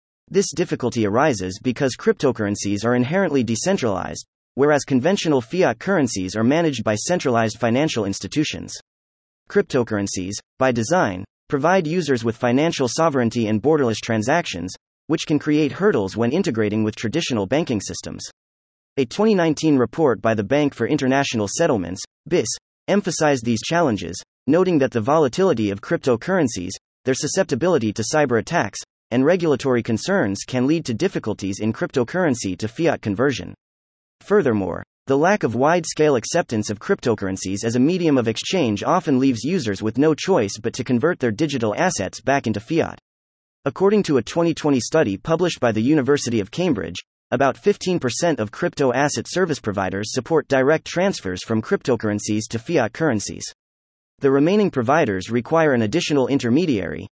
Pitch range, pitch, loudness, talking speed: 110-160 Hz, 130 Hz, -20 LUFS, 145 wpm